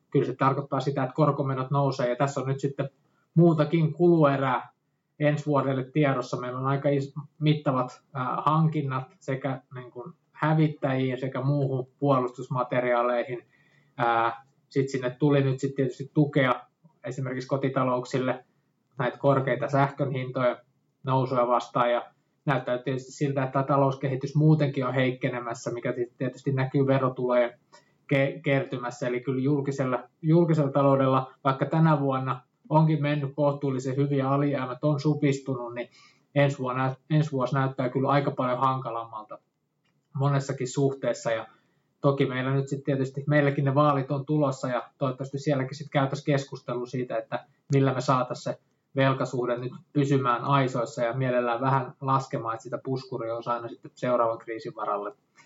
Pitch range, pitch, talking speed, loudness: 125-145 Hz, 135 Hz, 135 wpm, -27 LUFS